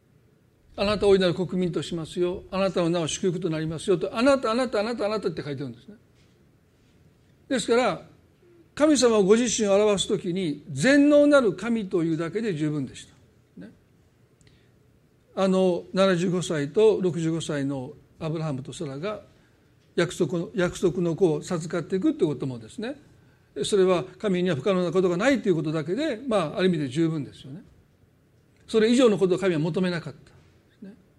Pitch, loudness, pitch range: 180 Hz, -24 LUFS, 155-205 Hz